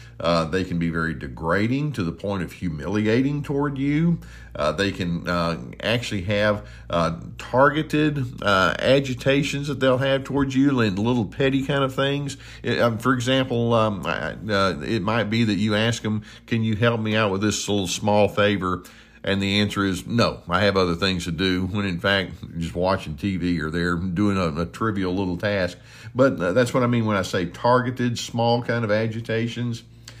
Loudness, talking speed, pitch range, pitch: -23 LUFS, 190 wpm, 95-125 Hz, 110 Hz